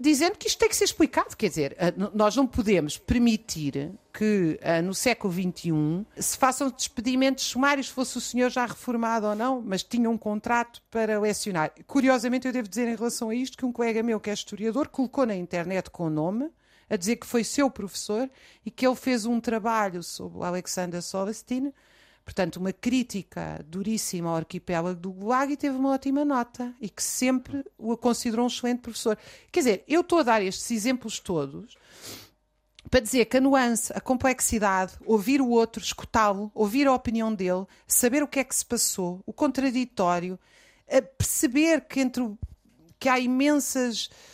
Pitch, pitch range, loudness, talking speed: 235 Hz, 200-260 Hz, -26 LUFS, 180 wpm